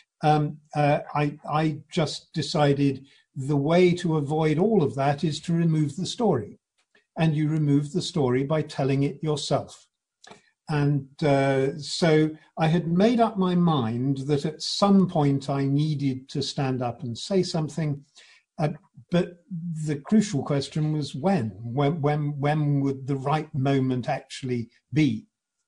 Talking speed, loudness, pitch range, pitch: 150 wpm, -25 LUFS, 140-160 Hz, 150 Hz